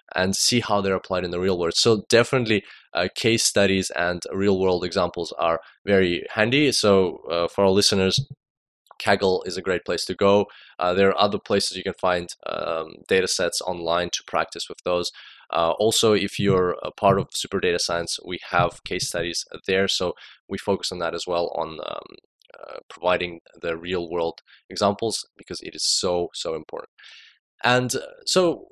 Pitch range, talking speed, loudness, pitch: 90-105 Hz, 180 wpm, -23 LUFS, 95 Hz